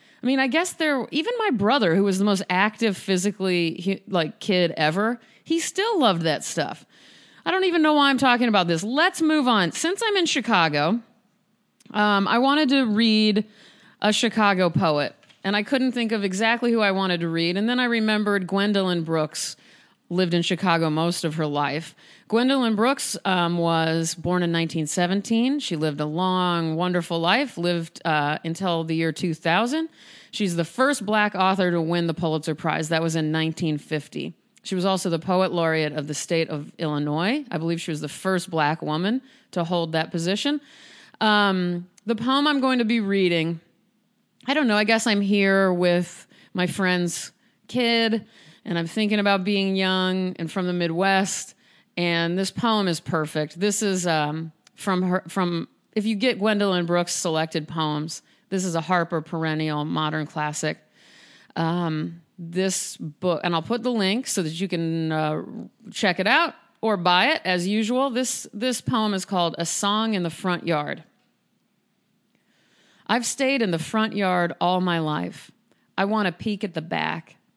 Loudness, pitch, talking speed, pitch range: -23 LUFS, 190 Hz, 175 wpm, 165-225 Hz